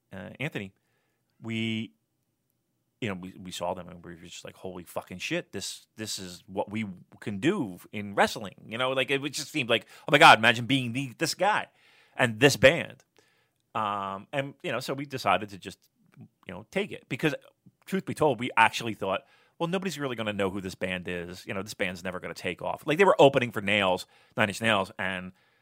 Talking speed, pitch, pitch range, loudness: 220 wpm, 110 Hz, 95-130 Hz, -27 LUFS